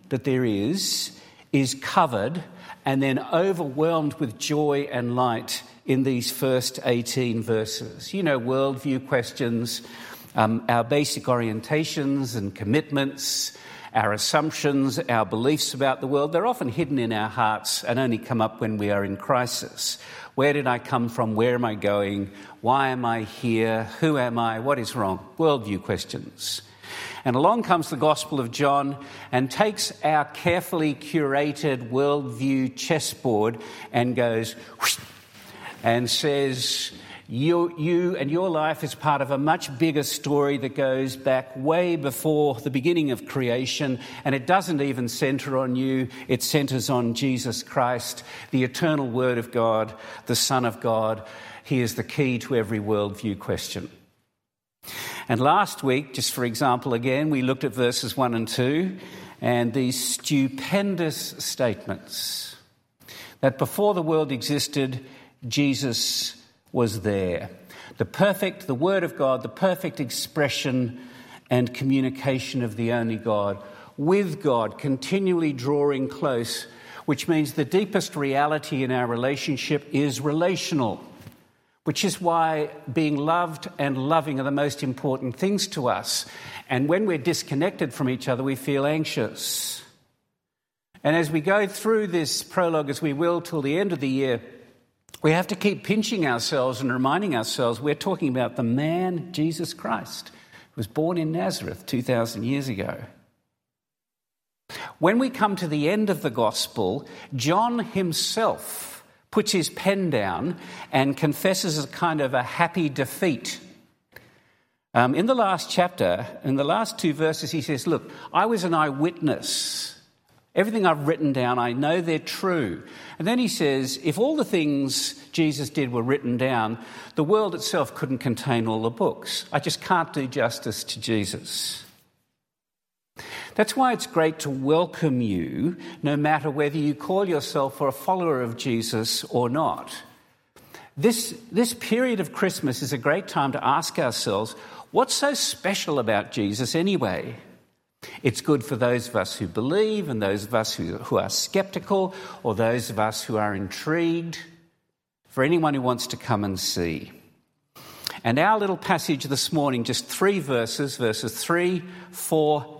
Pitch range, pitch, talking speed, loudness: 125-160 Hz, 140 Hz, 155 wpm, -24 LUFS